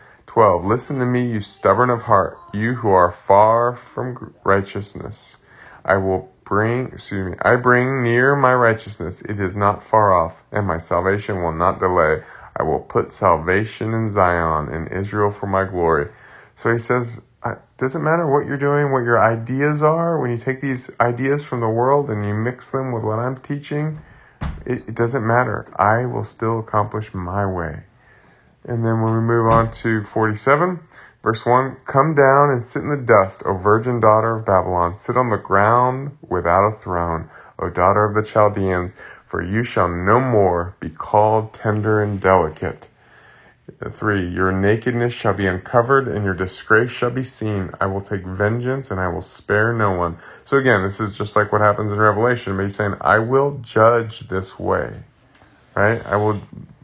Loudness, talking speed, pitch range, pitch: -19 LUFS, 180 wpm, 100-125 Hz, 110 Hz